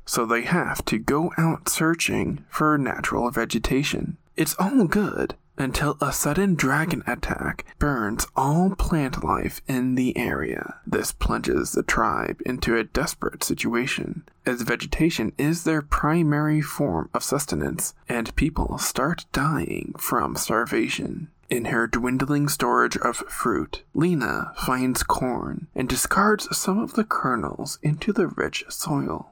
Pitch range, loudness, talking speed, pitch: 135-170 Hz, -24 LUFS, 135 wpm, 150 Hz